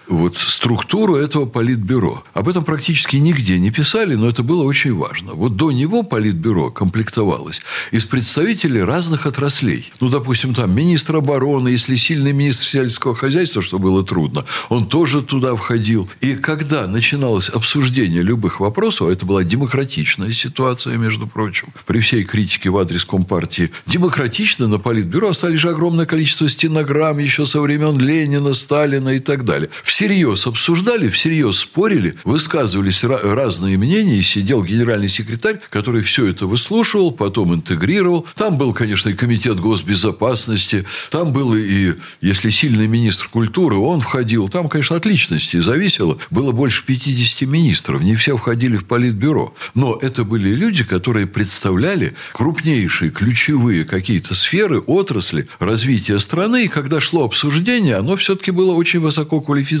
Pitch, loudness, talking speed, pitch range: 130 Hz, -16 LUFS, 145 wpm, 110-155 Hz